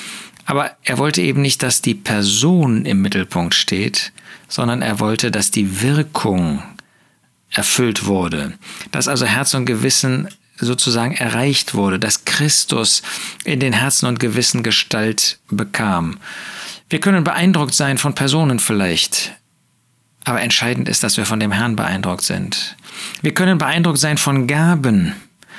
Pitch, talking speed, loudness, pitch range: 125 Hz, 140 wpm, -16 LUFS, 110-145 Hz